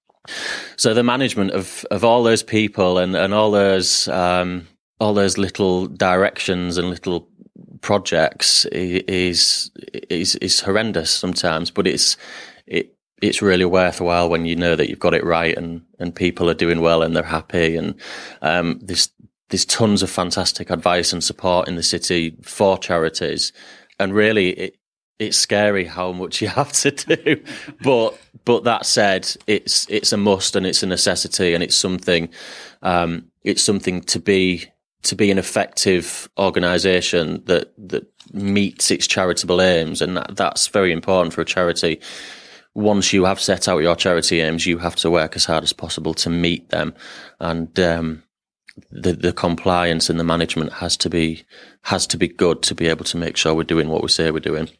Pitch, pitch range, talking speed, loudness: 90 Hz, 85-95 Hz, 175 wpm, -18 LUFS